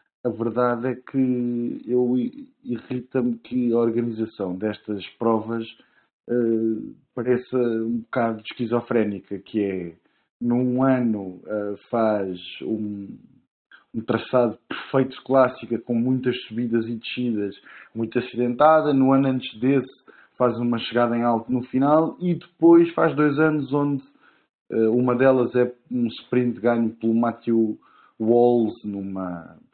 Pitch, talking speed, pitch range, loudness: 120 Hz, 130 wpm, 115-130 Hz, -23 LUFS